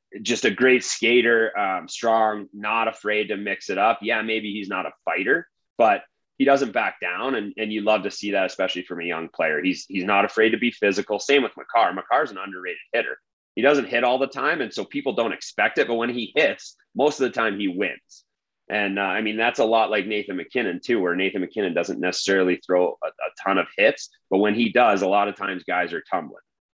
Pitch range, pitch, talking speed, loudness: 100-120 Hz, 110 Hz, 235 wpm, -22 LUFS